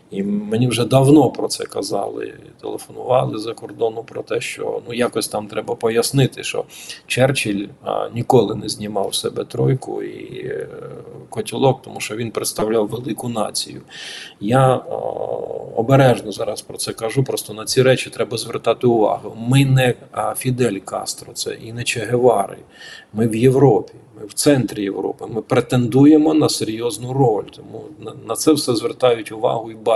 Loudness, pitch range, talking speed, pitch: -19 LUFS, 110-155 Hz, 155 wpm, 130 Hz